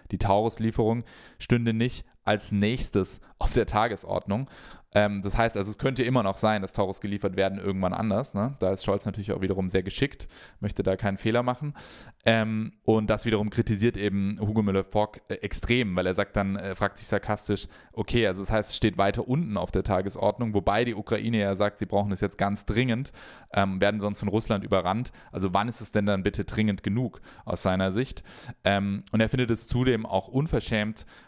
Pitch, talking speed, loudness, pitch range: 105 Hz, 200 wpm, -27 LUFS, 100-115 Hz